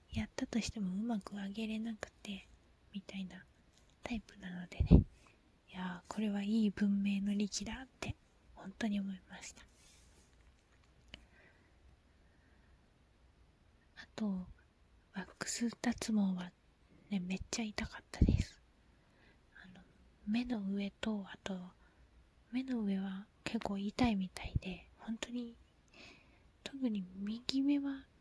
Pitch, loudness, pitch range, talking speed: 200 Hz, -39 LUFS, 180-225 Hz, 210 characters per minute